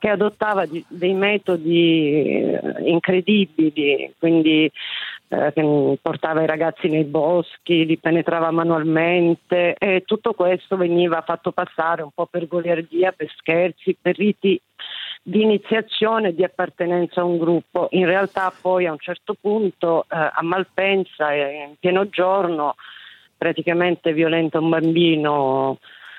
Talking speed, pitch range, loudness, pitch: 125 wpm, 160-185 Hz, -20 LUFS, 170 Hz